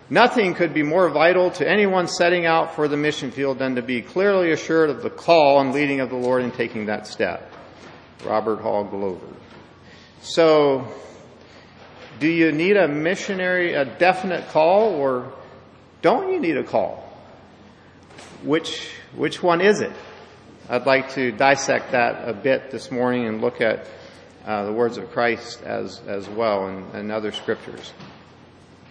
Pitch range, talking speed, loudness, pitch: 120-175 Hz, 160 wpm, -21 LUFS, 140 Hz